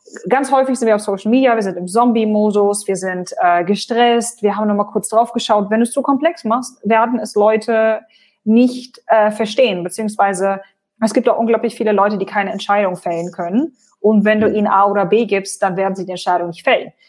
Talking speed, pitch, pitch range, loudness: 215 wpm, 215 Hz, 195-235 Hz, -16 LUFS